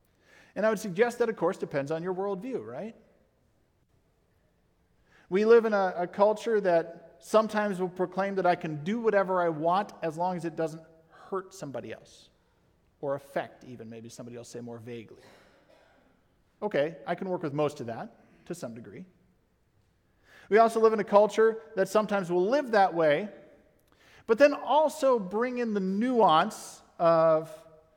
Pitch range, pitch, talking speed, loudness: 160-215 Hz, 185 Hz, 165 wpm, -27 LUFS